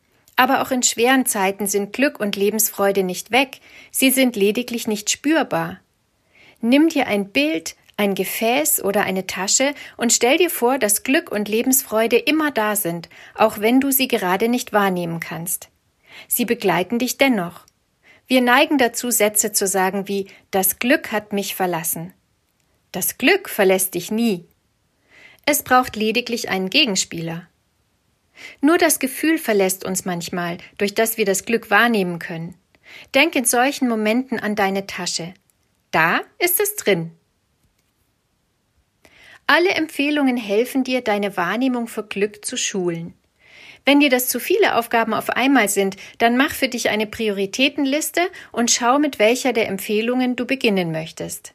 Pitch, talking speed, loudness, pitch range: 225 Hz, 150 wpm, -19 LUFS, 195-260 Hz